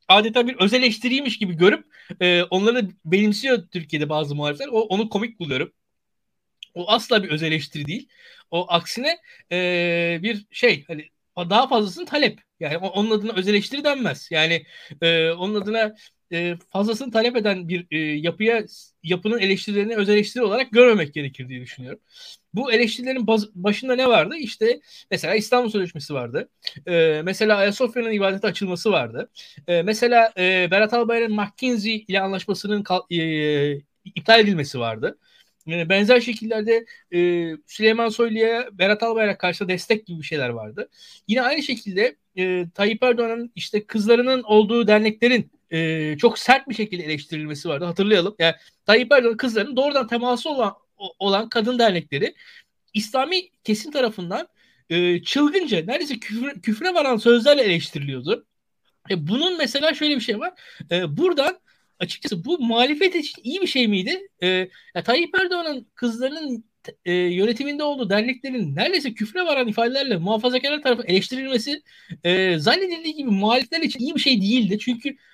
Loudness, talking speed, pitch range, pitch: -21 LUFS, 135 wpm, 180-250 Hz, 215 Hz